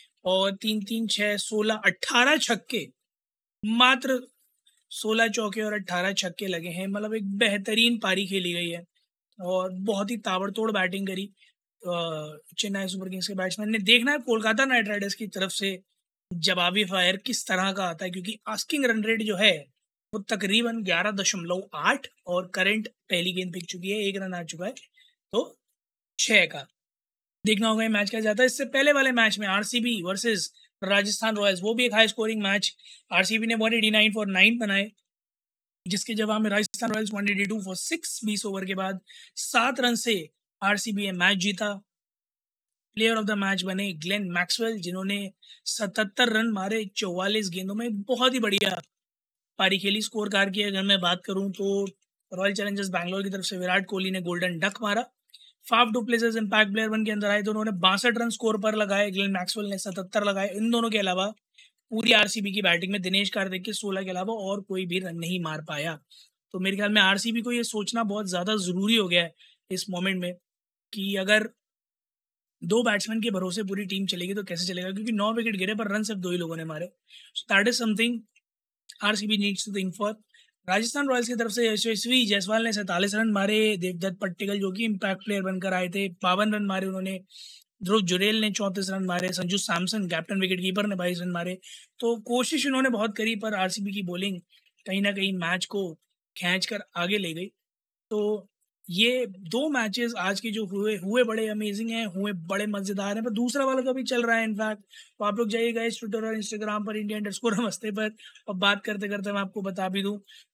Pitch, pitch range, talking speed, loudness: 205 Hz, 190-225 Hz, 195 wpm, -26 LUFS